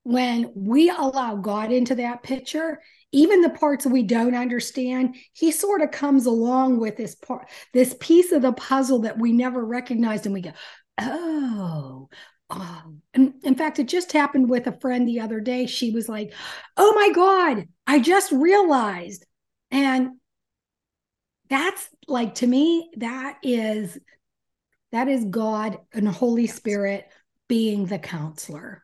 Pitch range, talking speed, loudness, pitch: 220-275 Hz, 150 wpm, -22 LUFS, 250 Hz